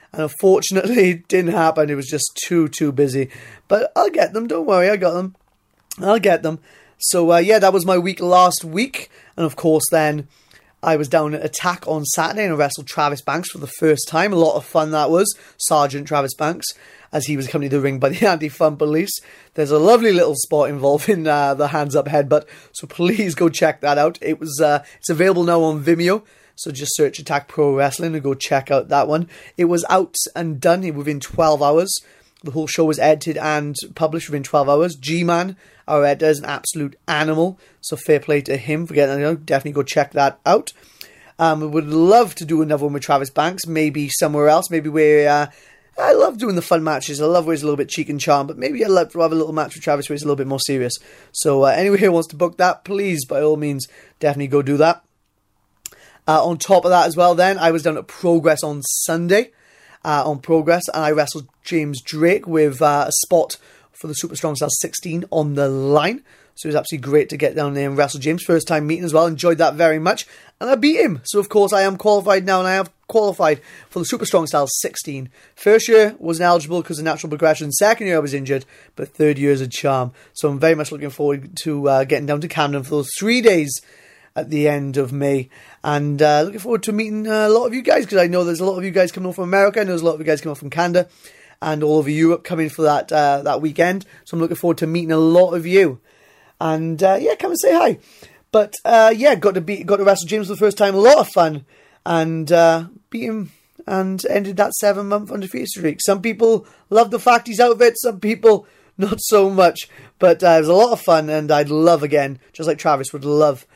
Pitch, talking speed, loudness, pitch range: 160 Hz, 245 wpm, -17 LUFS, 150-185 Hz